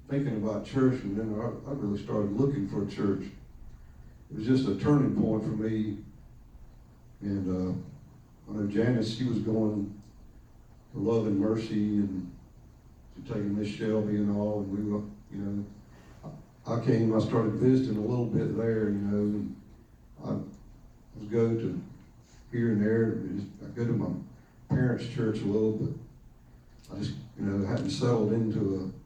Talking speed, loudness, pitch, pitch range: 170 wpm, -30 LUFS, 110 Hz, 100-115 Hz